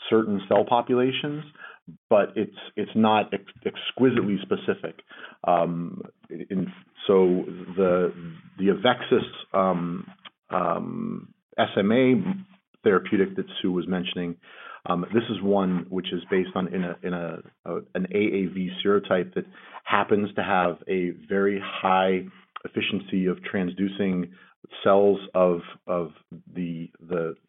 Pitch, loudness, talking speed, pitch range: 95 Hz, -25 LUFS, 120 wpm, 90-100 Hz